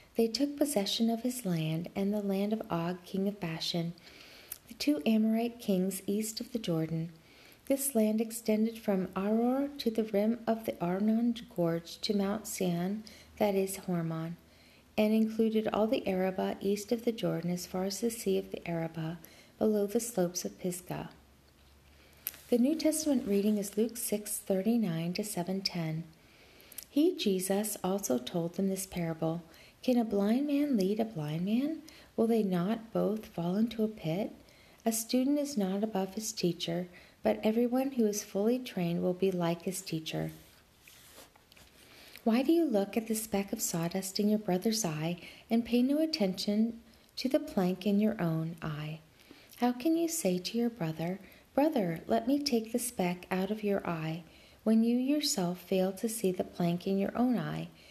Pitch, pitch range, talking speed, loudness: 200 Hz, 175-230 Hz, 175 wpm, -32 LUFS